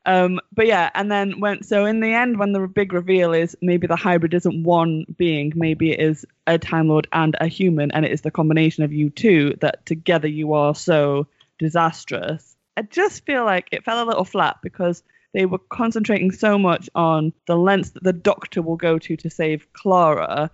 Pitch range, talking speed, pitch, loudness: 160-195 Hz, 205 wpm, 170 Hz, -20 LUFS